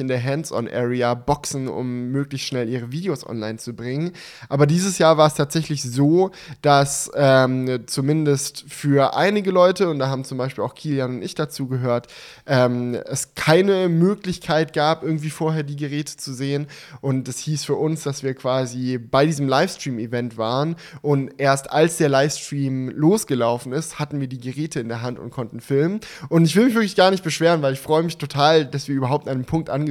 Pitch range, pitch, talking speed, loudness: 130-155 Hz, 140 Hz, 195 wpm, -21 LUFS